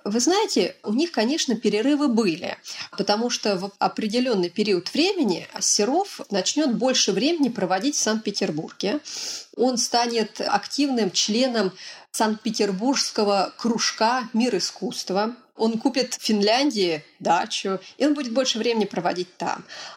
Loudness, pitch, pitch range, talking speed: -23 LUFS, 225 Hz, 205-265 Hz, 120 wpm